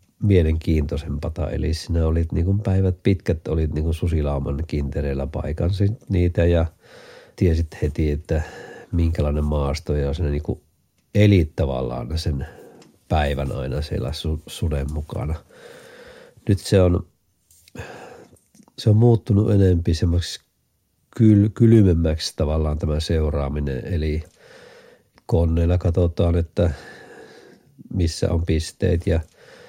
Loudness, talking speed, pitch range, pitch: -21 LUFS, 105 wpm, 75-95 Hz, 85 Hz